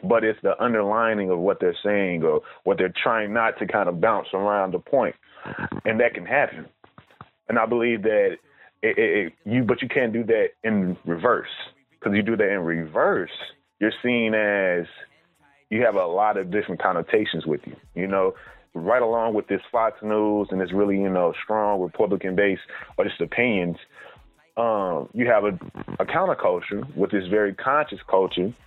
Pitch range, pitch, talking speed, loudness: 95-125 Hz, 105 Hz, 180 wpm, -23 LUFS